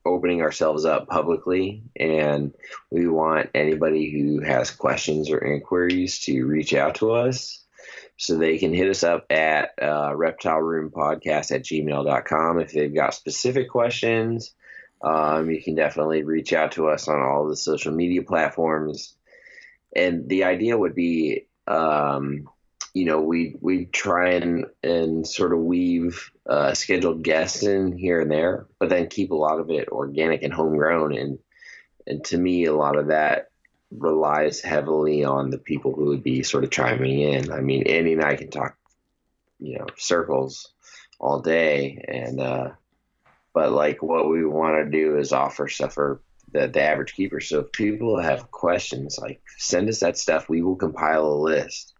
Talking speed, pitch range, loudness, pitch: 170 wpm, 75-90 Hz, -23 LUFS, 80 Hz